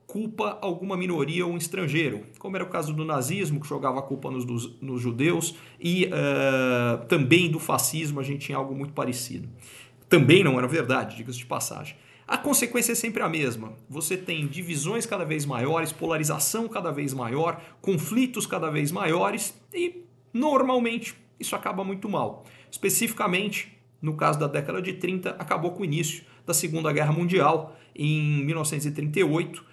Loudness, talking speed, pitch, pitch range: -26 LUFS, 165 wpm, 160 Hz, 140-185 Hz